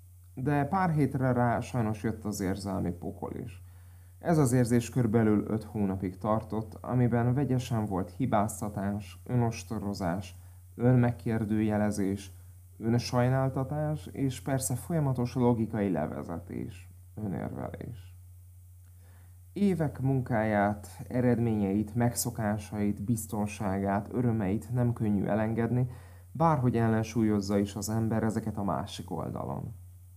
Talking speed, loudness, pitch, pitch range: 95 wpm, -30 LUFS, 110 Hz, 95-120 Hz